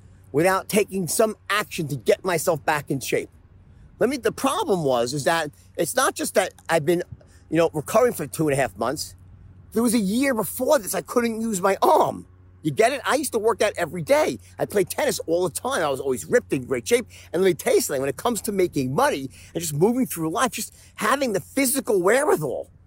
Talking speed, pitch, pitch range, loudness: 230 wpm, 185 Hz, 150-230 Hz, -23 LUFS